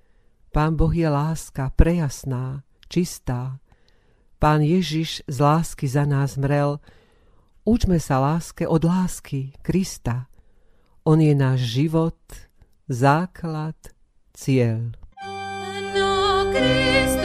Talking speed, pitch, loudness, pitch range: 85 wpm, 145 Hz, -22 LUFS, 130-165 Hz